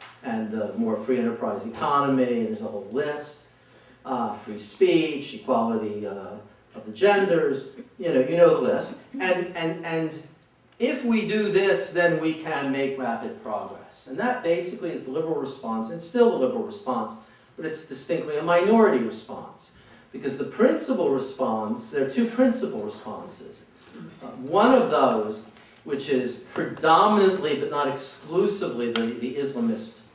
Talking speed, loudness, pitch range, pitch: 155 wpm, -24 LUFS, 125-195 Hz, 160 Hz